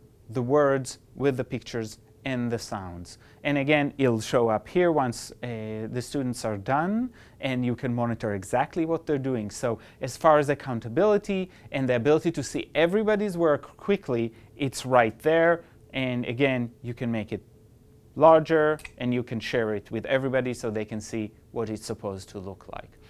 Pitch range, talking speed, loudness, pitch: 110-145 Hz, 175 wpm, -26 LUFS, 125 Hz